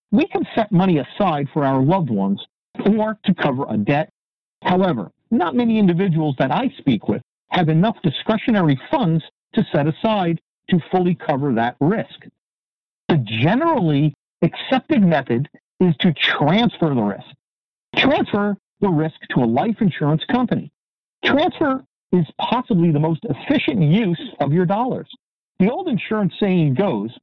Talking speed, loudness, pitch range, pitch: 145 wpm, -19 LUFS, 155-220 Hz, 180 Hz